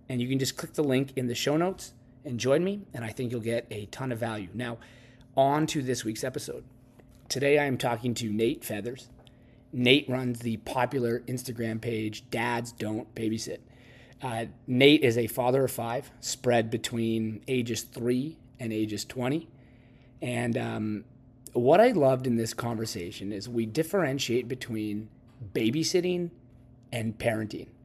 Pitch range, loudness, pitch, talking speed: 115-130 Hz, -29 LUFS, 125 Hz, 160 wpm